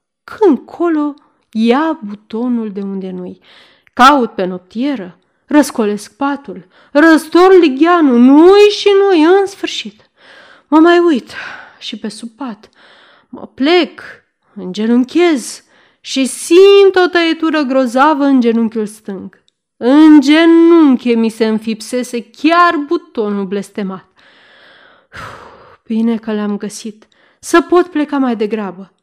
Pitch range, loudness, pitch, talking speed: 220-330 Hz, -11 LUFS, 265 Hz, 115 wpm